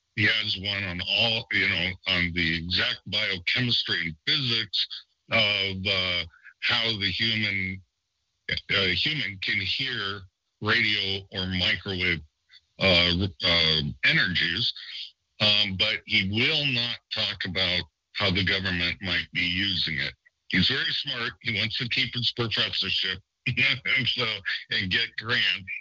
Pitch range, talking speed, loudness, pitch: 90-110 Hz, 130 wpm, -24 LUFS, 95 Hz